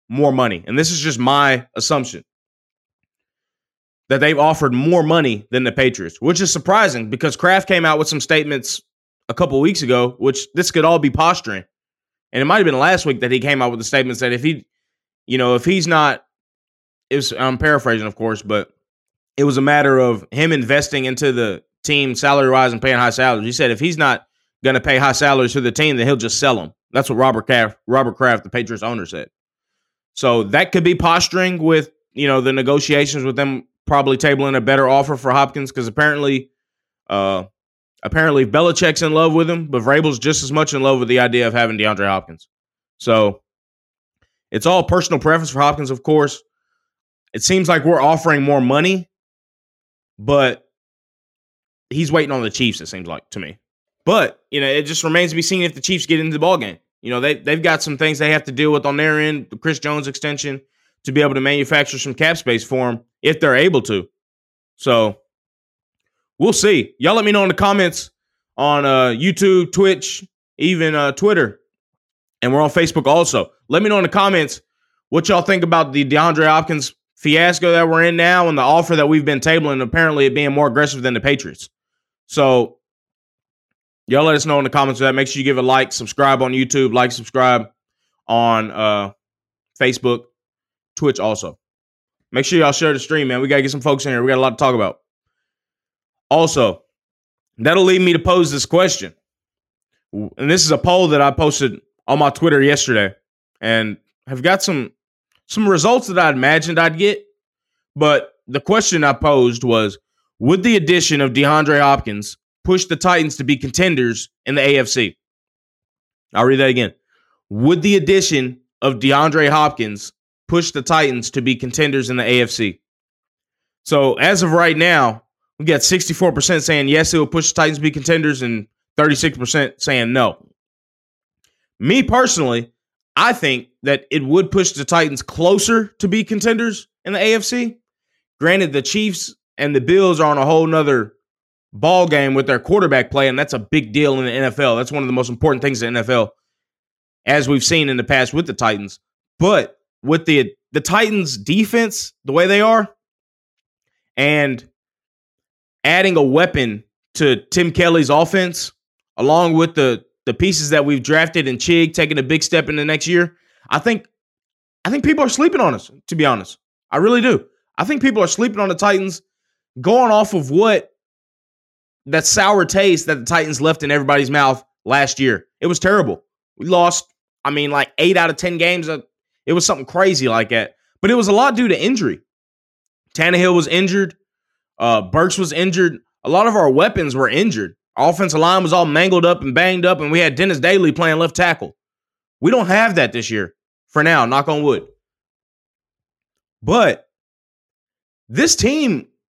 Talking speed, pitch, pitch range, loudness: 190 wpm, 150 Hz, 130-175 Hz, -15 LUFS